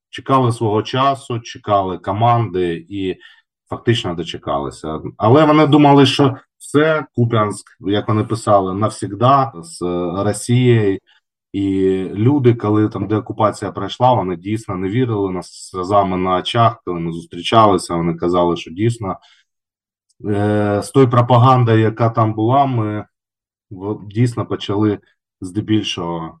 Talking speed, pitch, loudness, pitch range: 120 wpm, 105 Hz, -16 LUFS, 95-120 Hz